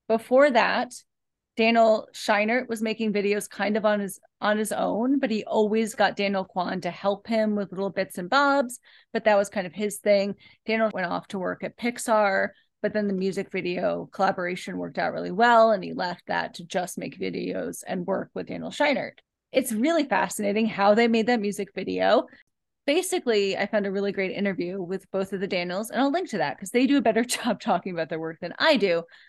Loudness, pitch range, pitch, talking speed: -25 LUFS, 195-225 Hz, 210 Hz, 215 wpm